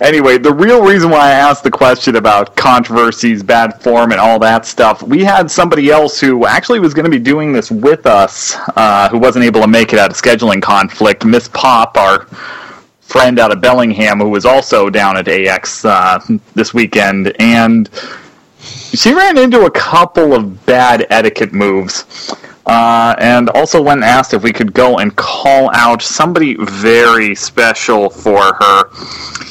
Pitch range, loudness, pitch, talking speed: 115-150 Hz, -8 LUFS, 120 Hz, 175 wpm